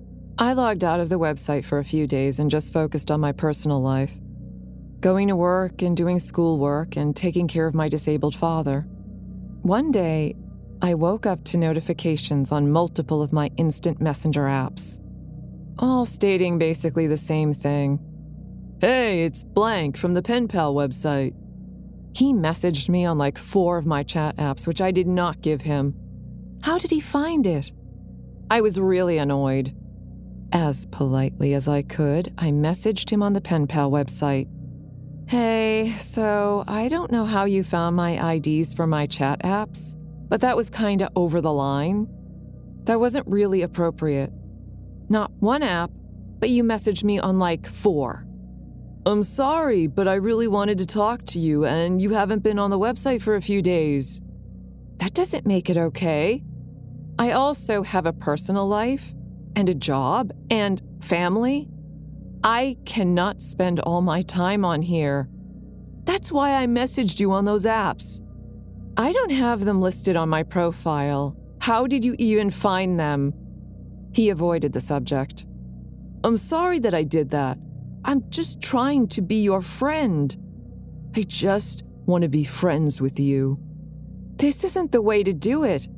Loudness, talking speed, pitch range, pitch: -23 LUFS, 160 wpm, 150-205 Hz, 170 Hz